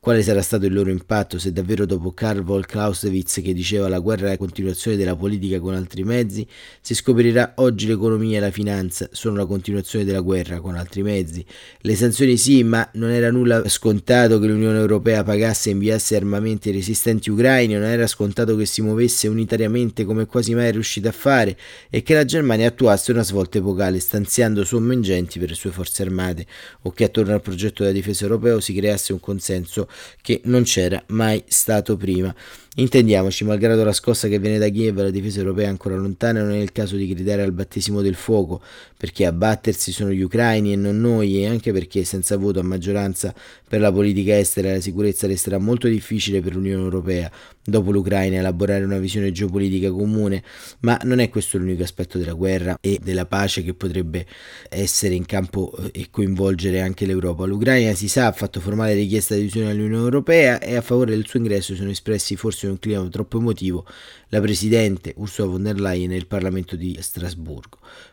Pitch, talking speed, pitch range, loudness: 100 Hz, 195 wpm, 95-110 Hz, -20 LUFS